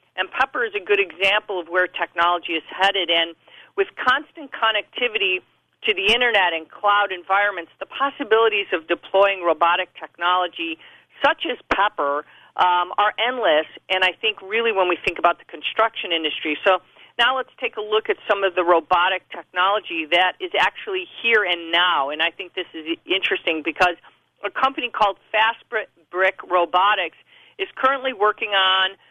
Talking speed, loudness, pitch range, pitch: 160 wpm, -20 LUFS, 175-270 Hz, 200 Hz